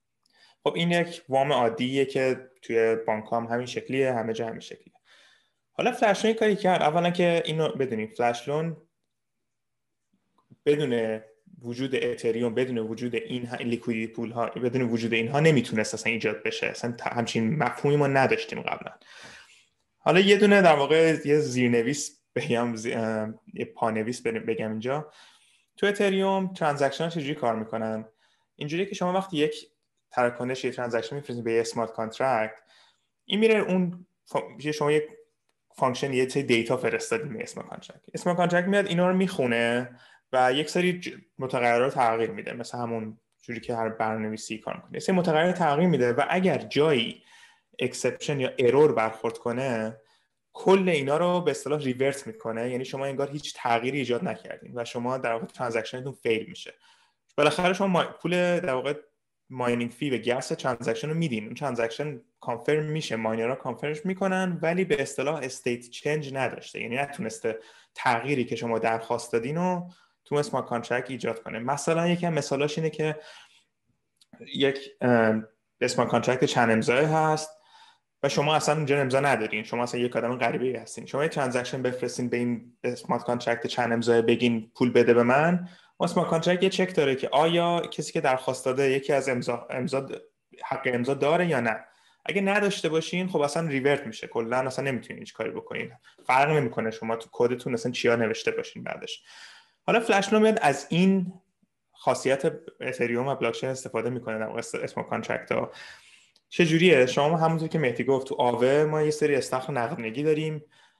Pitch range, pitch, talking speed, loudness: 120-165 Hz, 135 Hz, 160 wpm, -26 LUFS